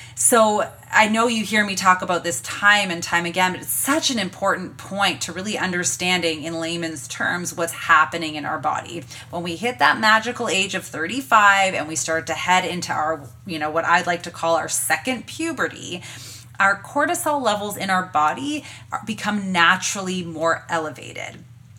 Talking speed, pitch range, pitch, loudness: 180 wpm, 160-205 Hz, 180 Hz, -20 LUFS